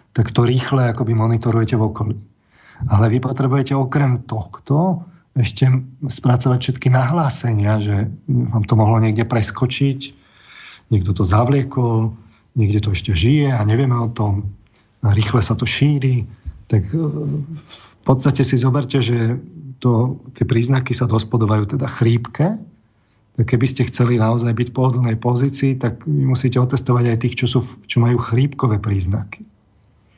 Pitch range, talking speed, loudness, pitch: 110-135 Hz, 145 wpm, -18 LUFS, 120 Hz